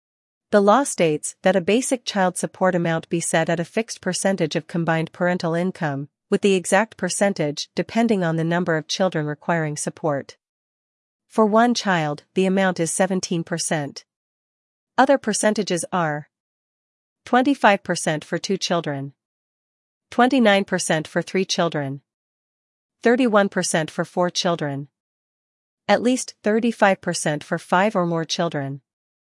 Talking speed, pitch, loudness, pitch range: 125 wpm, 180 Hz, -21 LUFS, 165-200 Hz